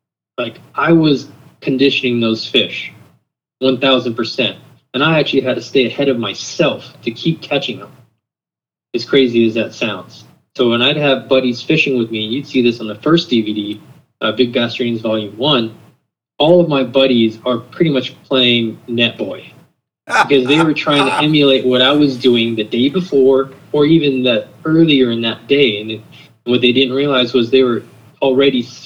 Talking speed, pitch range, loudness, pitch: 180 wpm, 115-140 Hz, -14 LUFS, 130 Hz